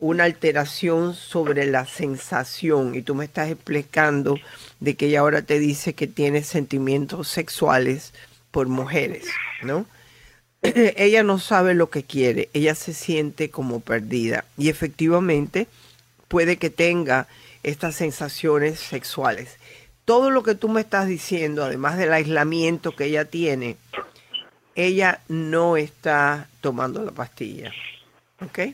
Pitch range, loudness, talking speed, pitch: 140-170 Hz, -22 LUFS, 130 wpm, 155 Hz